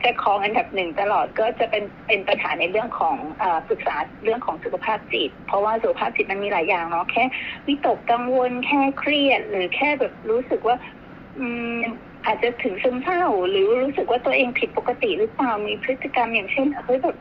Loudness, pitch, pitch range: -22 LUFS, 250 Hz, 225-290 Hz